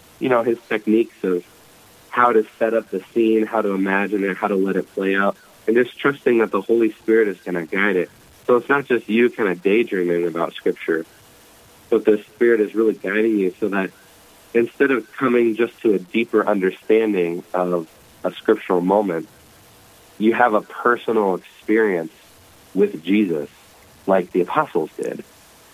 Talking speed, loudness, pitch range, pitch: 175 wpm, -20 LUFS, 95-115 Hz, 105 Hz